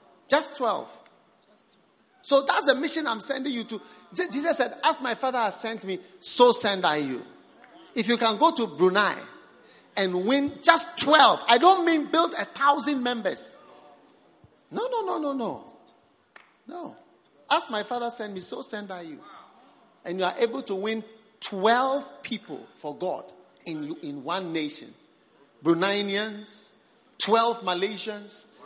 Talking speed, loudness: 150 wpm, -24 LUFS